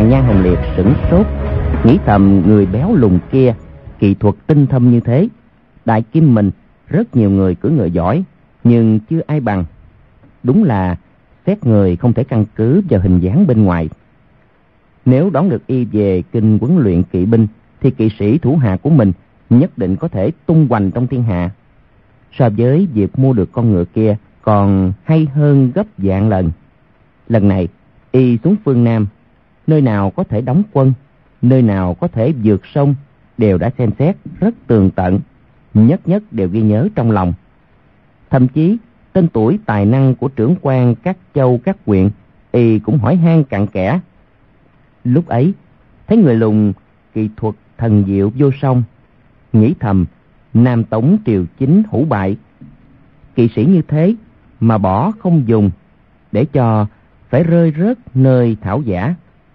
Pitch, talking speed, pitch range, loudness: 115 Hz, 170 wpm, 100-140 Hz, -13 LUFS